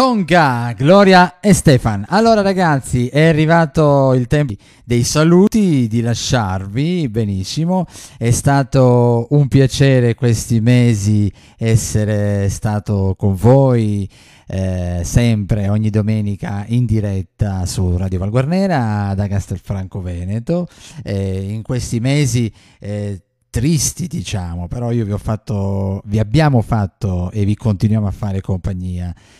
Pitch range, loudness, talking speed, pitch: 100-135 Hz, -15 LUFS, 115 wpm, 115 Hz